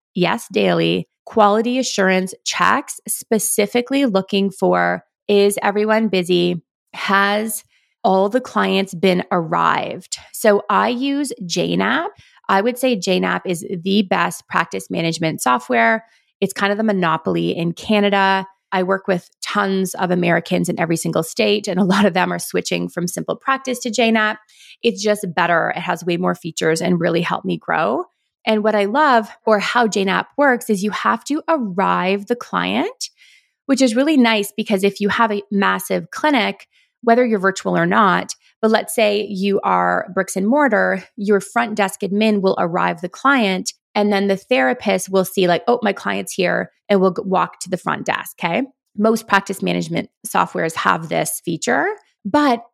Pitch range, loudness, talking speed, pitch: 185-230 Hz, -18 LUFS, 165 wpm, 200 Hz